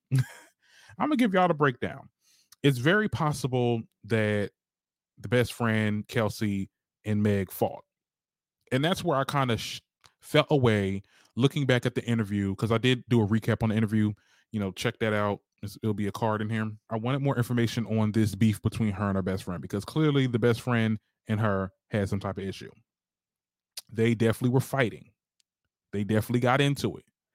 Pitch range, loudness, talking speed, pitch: 105-130 Hz, -28 LUFS, 190 wpm, 115 Hz